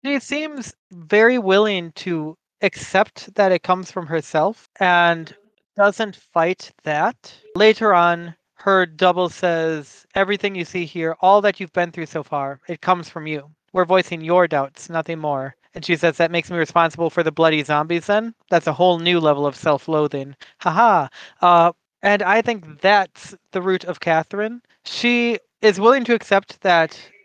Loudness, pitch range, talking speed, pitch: -19 LUFS, 165-200 Hz, 170 wpm, 175 Hz